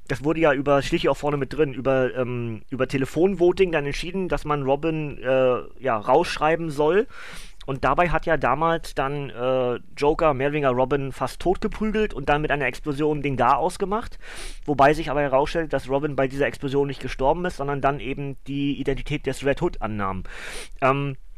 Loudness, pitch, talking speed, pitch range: -23 LUFS, 140 Hz, 180 wpm, 130-155 Hz